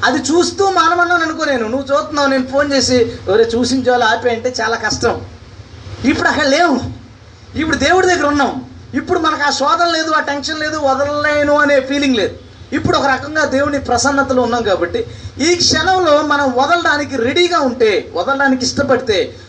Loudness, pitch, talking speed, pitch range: -14 LUFS, 285 Hz, 150 wpm, 255-315 Hz